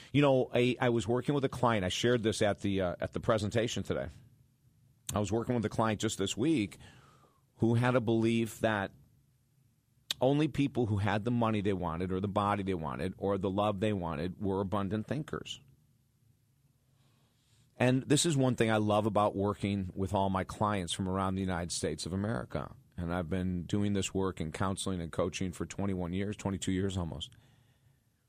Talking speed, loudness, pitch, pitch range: 190 wpm, -32 LUFS, 110 Hz, 95-125 Hz